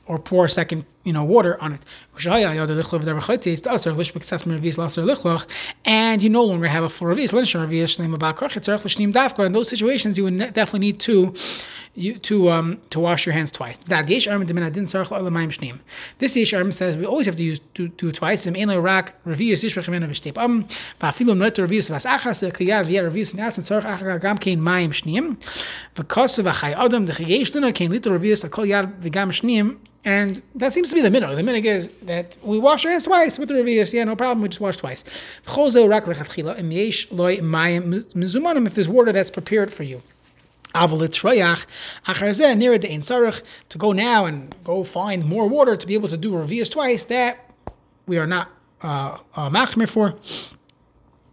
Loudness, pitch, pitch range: -20 LUFS, 195 Hz, 170-220 Hz